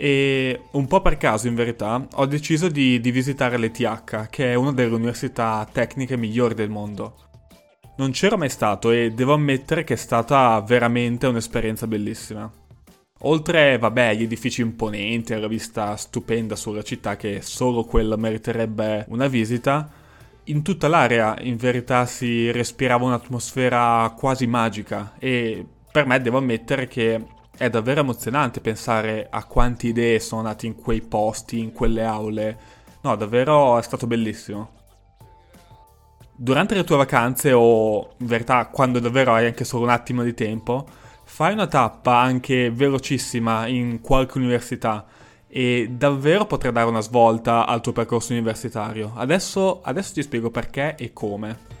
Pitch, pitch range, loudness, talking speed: 120 Hz, 110-130 Hz, -21 LUFS, 150 wpm